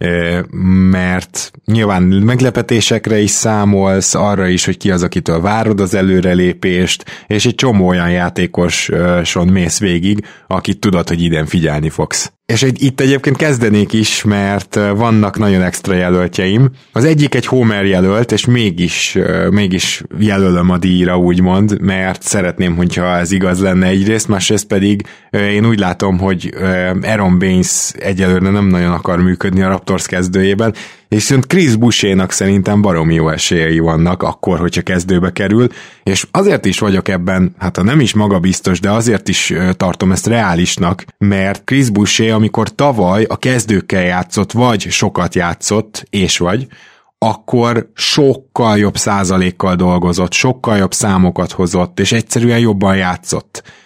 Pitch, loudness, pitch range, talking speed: 95 Hz, -12 LUFS, 90-110 Hz, 140 wpm